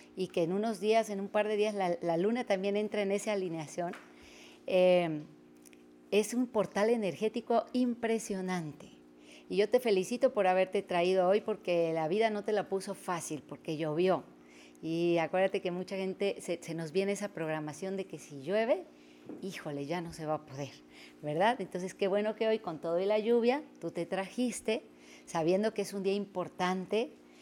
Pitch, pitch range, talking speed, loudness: 185 Hz, 160-205 Hz, 185 wpm, -33 LUFS